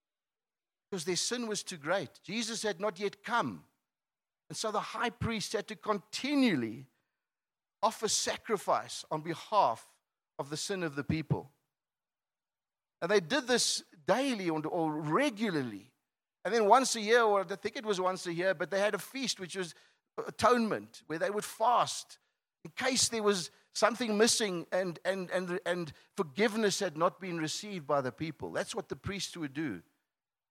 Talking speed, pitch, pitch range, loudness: 165 wpm, 200 Hz, 175-220 Hz, -32 LUFS